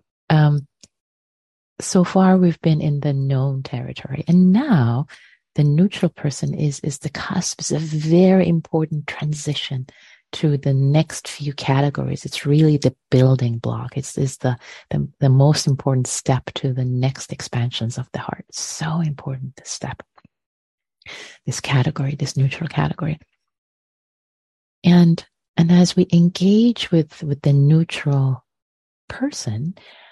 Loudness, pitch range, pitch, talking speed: -19 LUFS, 135-165 Hz, 145 Hz, 135 wpm